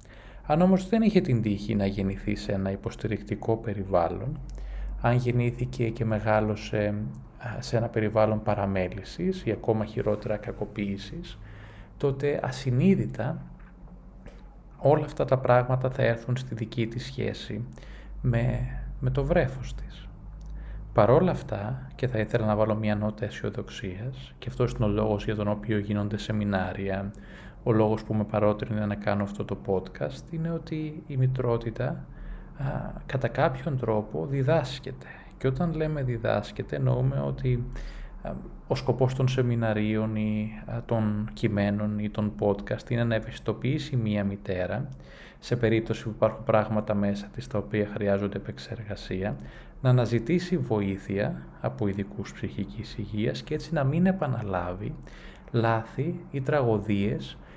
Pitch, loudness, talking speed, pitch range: 110 Hz, -28 LUFS, 130 wpm, 105-130 Hz